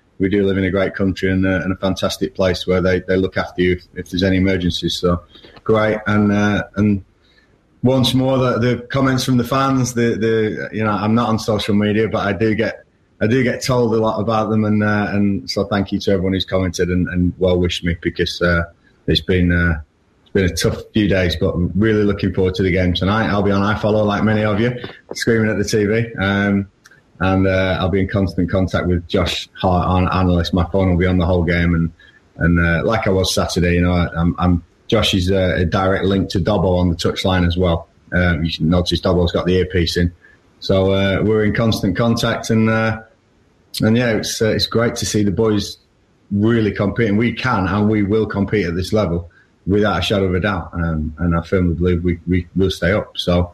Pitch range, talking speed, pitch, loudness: 90-110 Hz, 235 wpm, 95 Hz, -17 LUFS